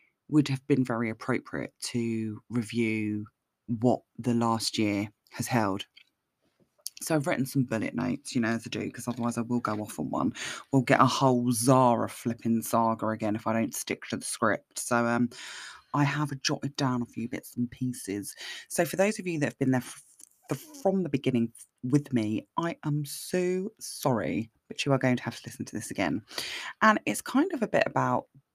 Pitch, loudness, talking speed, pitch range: 120 Hz, -29 LUFS, 205 wpm, 115-140 Hz